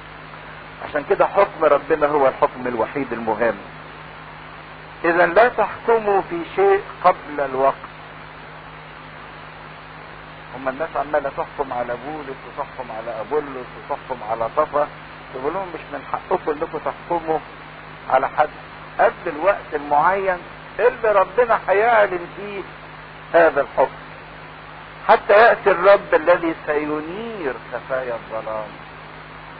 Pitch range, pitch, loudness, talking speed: 110-175 Hz, 145 Hz, -20 LUFS, 105 wpm